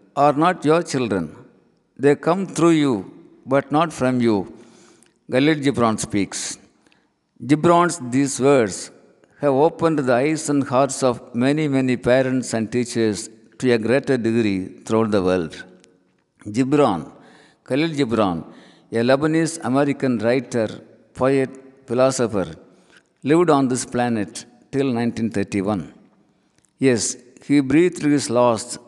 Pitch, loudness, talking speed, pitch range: 130 Hz, -20 LUFS, 115 wpm, 115-145 Hz